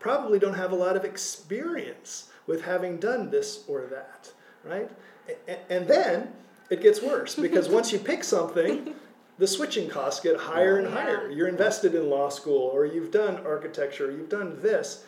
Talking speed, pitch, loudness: 175 wpm, 205 Hz, -26 LUFS